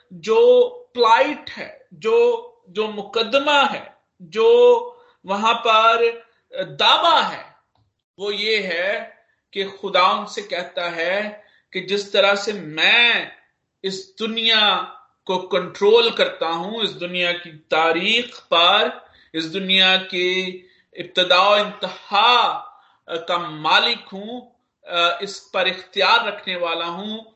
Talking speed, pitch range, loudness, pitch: 110 wpm, 180-245 Hz, -18 LUFS, 200 Hz